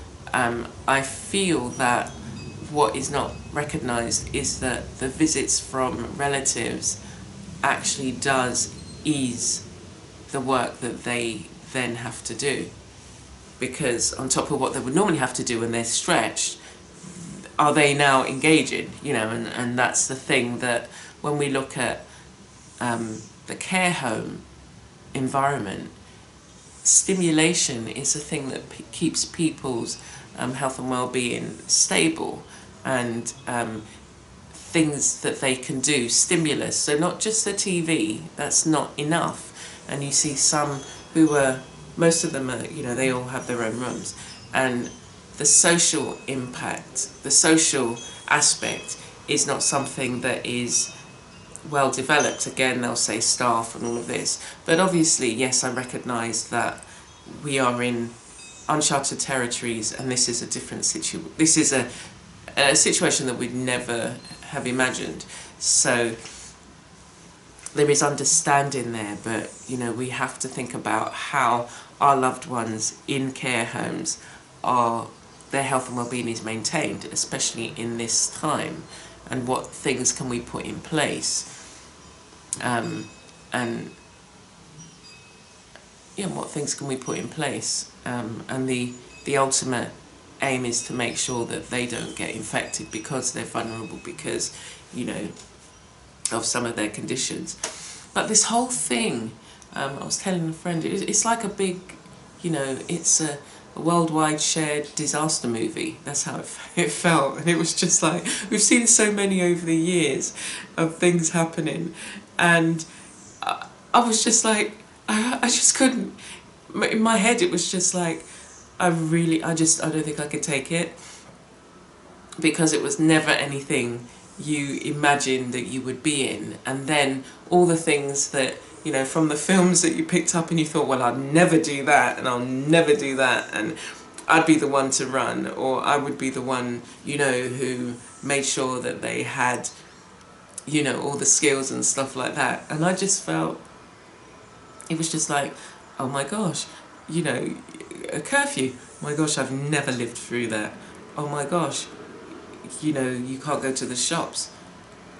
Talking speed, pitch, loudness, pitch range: 155 wpm, 135 Hz, -23 LUFS, 120-160 Hz